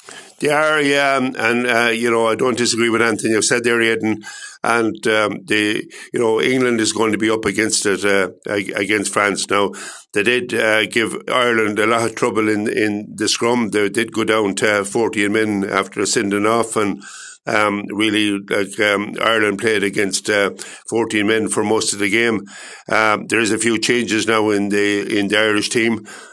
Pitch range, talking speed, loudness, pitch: 105-115 Hz, 195 wpm, -17 LUFS, 110 Hz